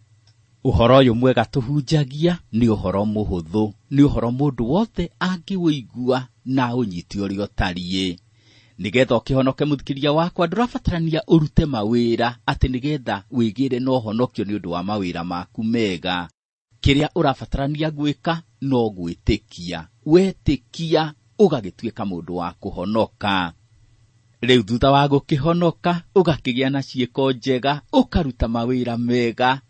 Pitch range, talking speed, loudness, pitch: 110-145 Hz, 115 wpm, -21 LUFS, 125 Hz